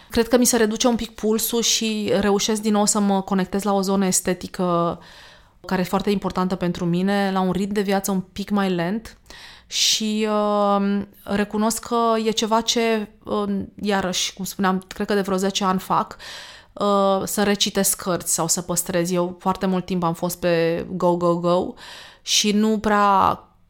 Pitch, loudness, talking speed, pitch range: 200 Hz, -21 LUFS, 180 wpm, 185-210 Hz